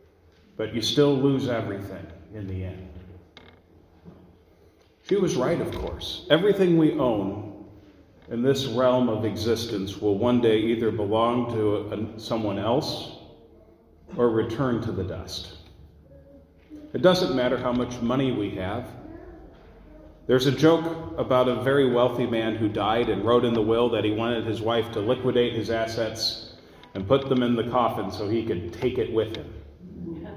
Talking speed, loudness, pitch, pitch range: 160 wpm, -24 LUFS, 115 Hz, 100-125 Hz